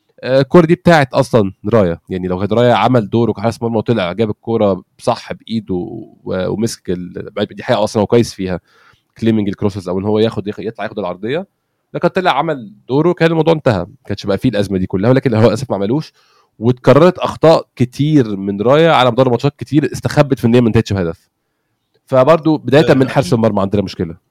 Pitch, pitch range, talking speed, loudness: 115 Hz, 100-135 Hz, 190 wpm, -14 LUFS